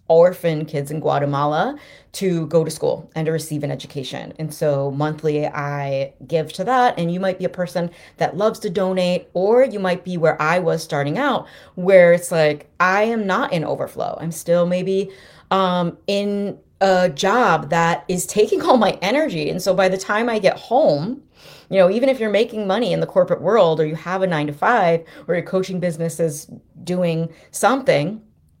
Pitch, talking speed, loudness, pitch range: 175 Hz, 195 wpm, -19 LUFS, 160-195 Hz